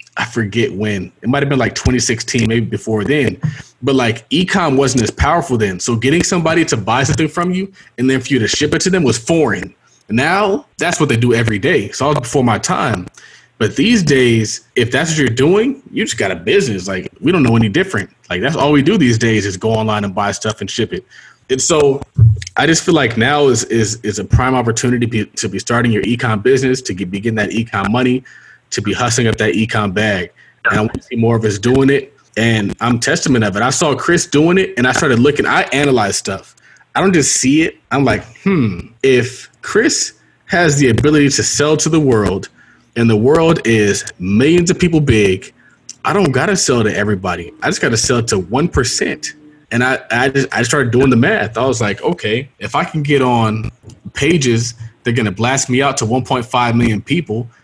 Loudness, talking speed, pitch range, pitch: -14 LUFS, 225 wpm, 110-145 Hz, 125 Hz